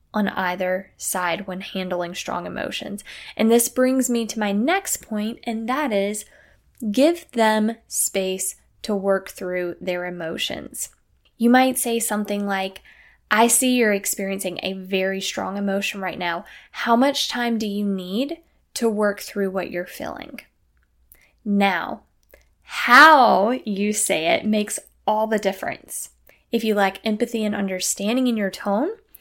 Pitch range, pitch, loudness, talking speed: 190-235 Hz, 210 Hz, -21 LUFS, 145 wpm